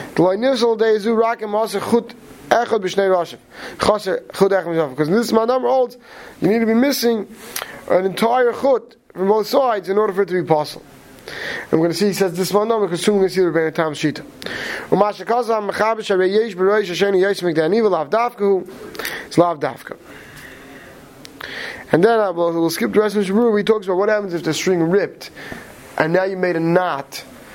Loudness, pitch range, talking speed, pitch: -18 LUFS, 180-230 Hz, 155 wpm, 205 Hz